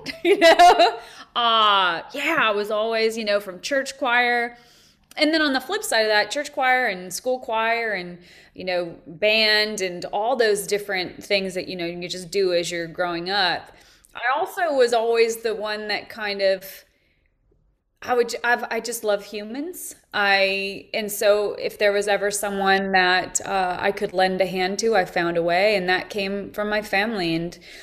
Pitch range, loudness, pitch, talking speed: 190-235 Hz, -21 LUFS, 205 Hz, 190 wpm